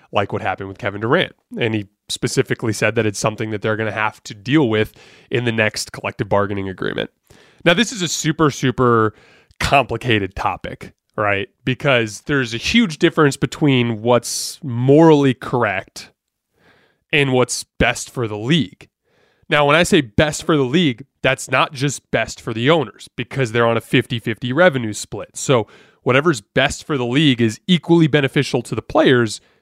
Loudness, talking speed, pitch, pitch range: -18 LUFS, 175 wpm, 125 Hz, 110-145 Hz